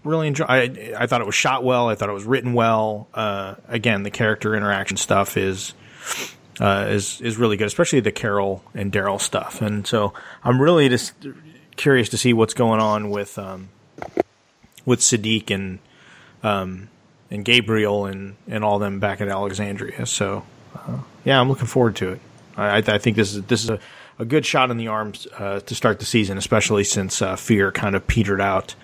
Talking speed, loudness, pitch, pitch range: 195 wpm, -20 LUFS, 105 Hz, 100-120 Hz